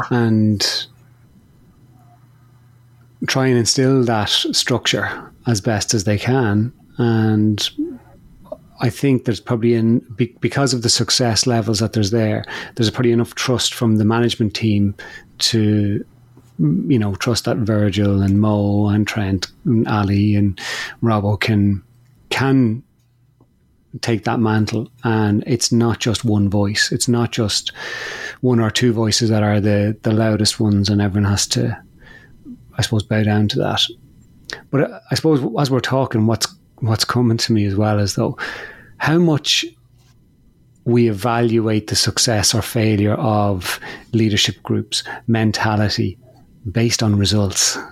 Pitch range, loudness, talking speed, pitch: 105-120 Hz, -17 LUFS, 140 wpm, 115 Hz